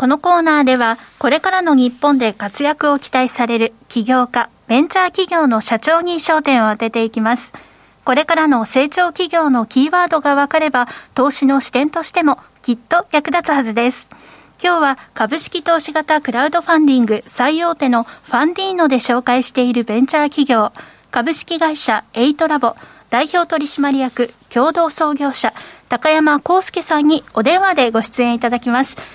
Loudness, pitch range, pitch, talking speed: -15 LUFS, 245-320 Hz, 280 Hz, 350 characters per minute